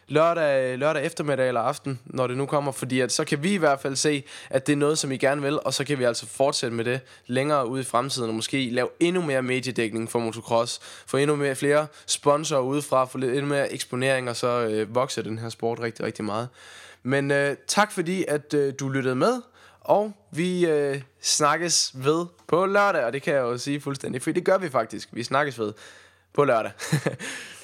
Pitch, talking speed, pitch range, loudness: 135 Hz, 215 wpm, 125-150 Hz, -25 LUFS